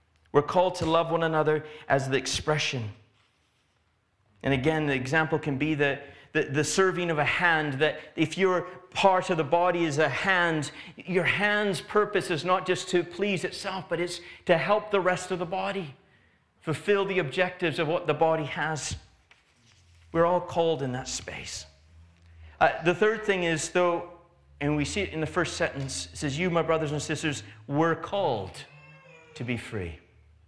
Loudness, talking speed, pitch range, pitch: -27 LUFS, 175 wpm, 130-180 Hz, 160 Hz